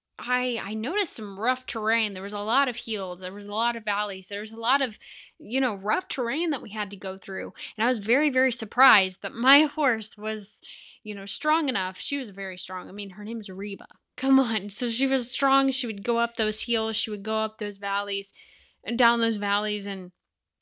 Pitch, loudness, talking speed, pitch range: 220 Hz, -26 LUFS, 235 wpm, 200-250 Hz